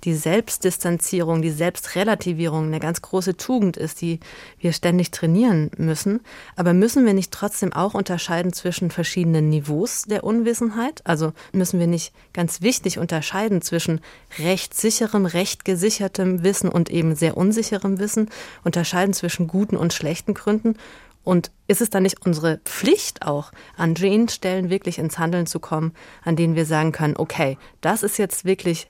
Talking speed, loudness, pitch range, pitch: 160 wpm, -21 LUFS, 165-205 Hz, 180 Hz